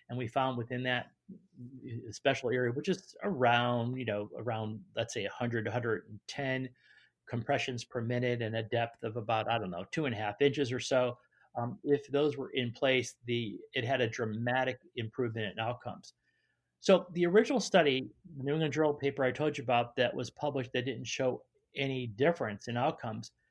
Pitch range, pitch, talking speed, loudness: 120-140 Hz, 125 Hz, 185 wpm, -33 LUFS